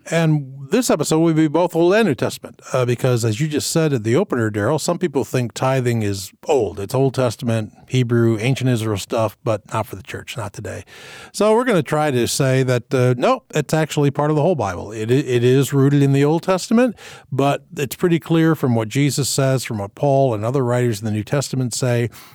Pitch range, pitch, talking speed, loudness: 120-155 Hz, 135 Hz, 225 wpm, -19 LUFS